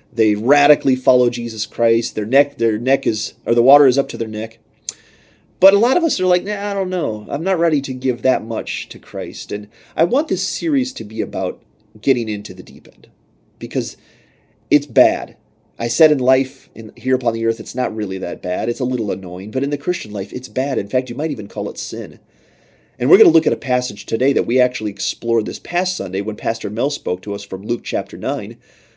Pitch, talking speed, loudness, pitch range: 120 Hz, 230 wpm, -18 LUFS, 105-140 Hz